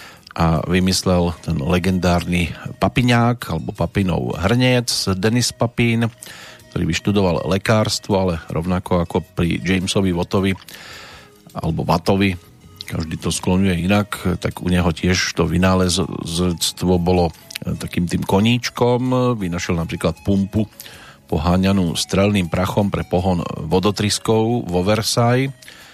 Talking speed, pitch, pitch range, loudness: 105 wpm, 95 Hz, 90-105 Hz, -19 LUFS